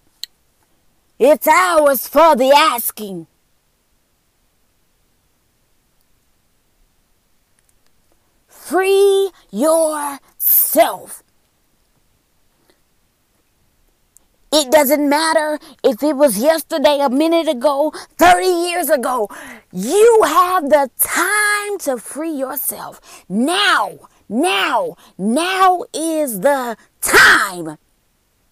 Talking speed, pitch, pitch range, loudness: 70 wpm, 305 Hz, 275-335 Hz, -14 LUFS